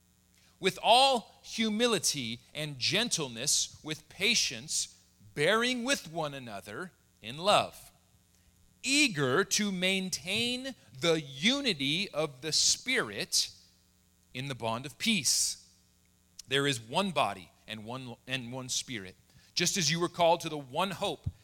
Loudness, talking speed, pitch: -29 LUFS, 125 wpm, 140 Hz